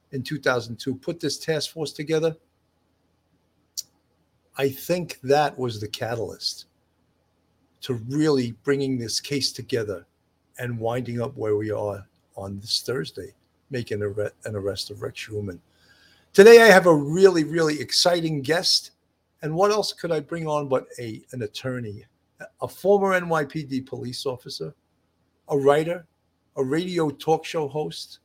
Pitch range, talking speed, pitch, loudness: 100-155 Hz, 140 wpm, 130 Hz, -23 LUFS